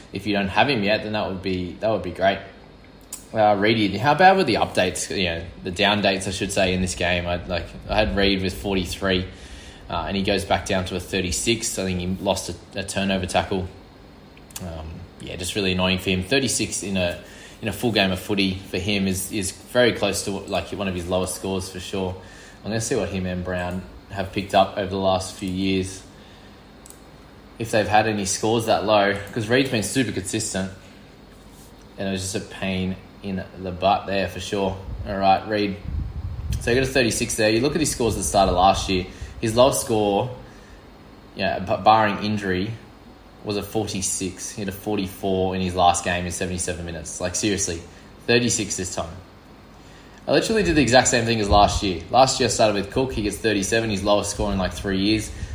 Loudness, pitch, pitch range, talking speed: -22 LUFS, 95 Hz, 95-105 Hz, 220 wpm